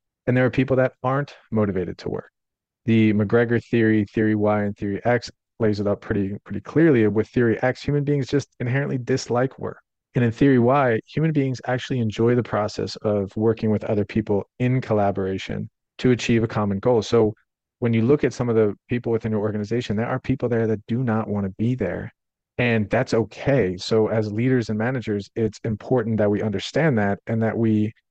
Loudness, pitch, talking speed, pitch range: -22 LUFS, 115 Hz, 200 wpm, 105-125 Hz